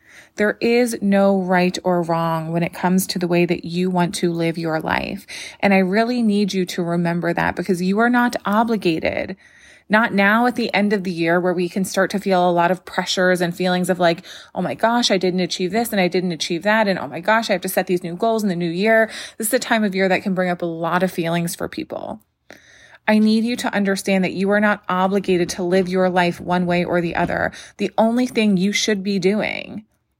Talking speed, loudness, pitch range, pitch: 245 wpm, -19 LUFS, 175-210 Hz, 185 Hz